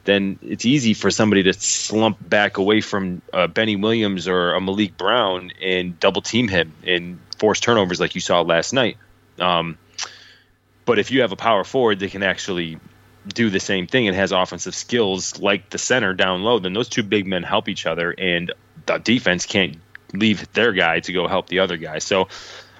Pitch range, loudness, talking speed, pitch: 90-105 Hz, -19 LUFS, 195 wpm, 95 Hz